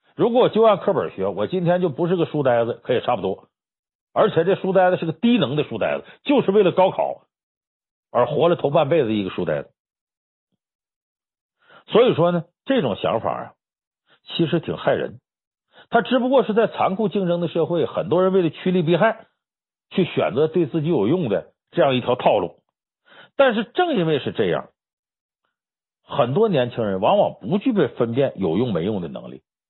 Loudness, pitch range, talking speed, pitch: -20 LUFS, 160-215 Hz, 265 characters per minute, 180 Hz